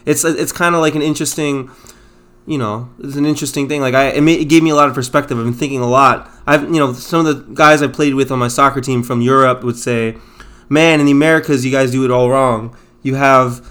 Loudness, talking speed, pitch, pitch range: -13 LUFS, 260 wpm, 135 Hz, 125-150 Hz